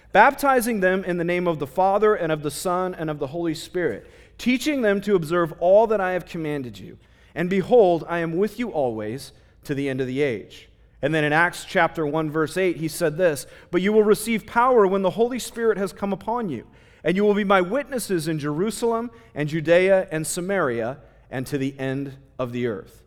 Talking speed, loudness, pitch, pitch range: 215 wpm, -22 LUFS, 175 Hz, 150-205 Hz